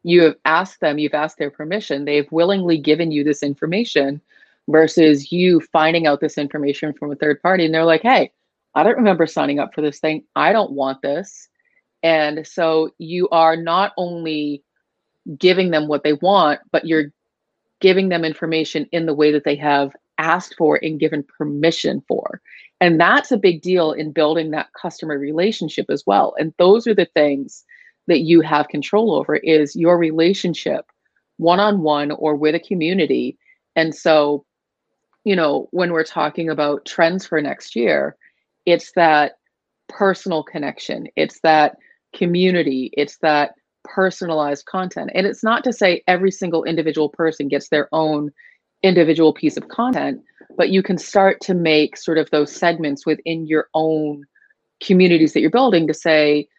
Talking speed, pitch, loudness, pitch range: 170 wpm, 160 Hz, -17 LUFS, 150-175 Hz